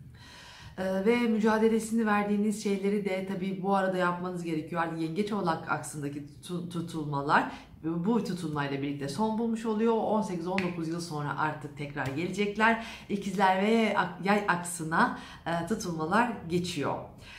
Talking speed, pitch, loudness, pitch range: 115 wpm, 185 Hz, -30 LUFS, 165-210 Hz